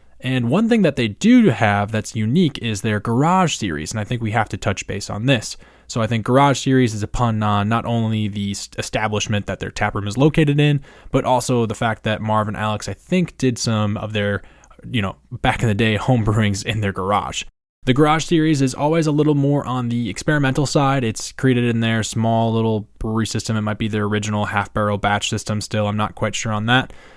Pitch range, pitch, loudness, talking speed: 105-130 Hz, 115 Hz, -19 LUFS, 220 wpm